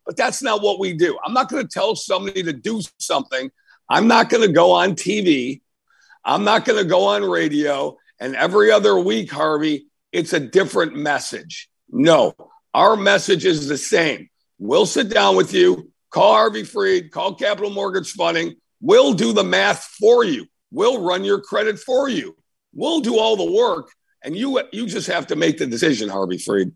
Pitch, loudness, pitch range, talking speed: 205 Hz, -18 LUFS, 170-275 Hz, 190 wpm